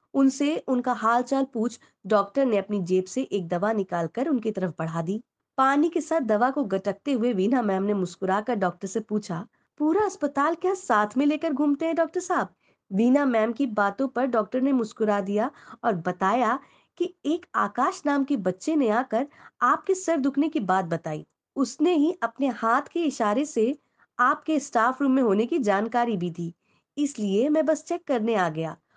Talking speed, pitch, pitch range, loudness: 185 wpm, 245 Hz, 205-290 Hz, -25 LUFS